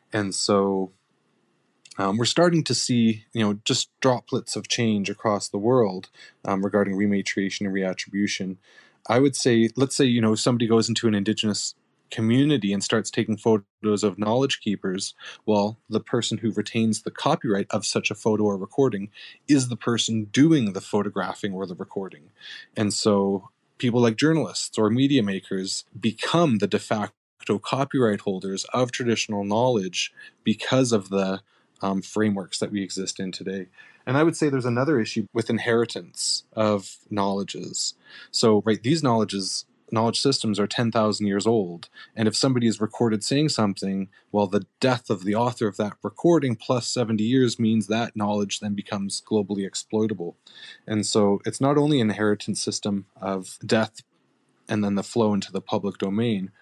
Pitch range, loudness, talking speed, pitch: 100-120 Hz, -24 LUFS, 165 wpm, 110 Hz